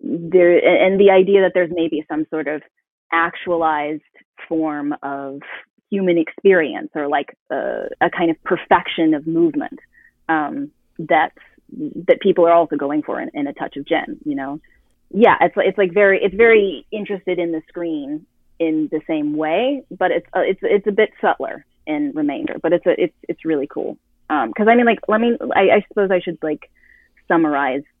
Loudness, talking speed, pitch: -18 LUFS, 185 wpm, 195 Hz